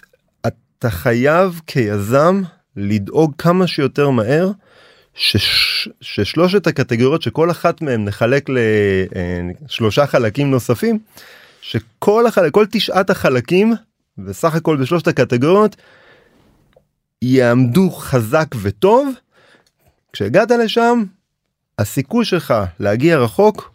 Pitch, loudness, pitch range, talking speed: 155 Hz, -15 LUFS, 125-195 Hz, 90 wpm